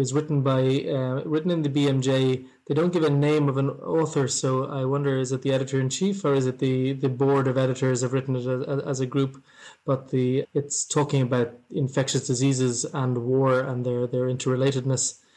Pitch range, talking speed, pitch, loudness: 130-140 Hz, 205 wpm, 135 Hz, -24 LUFS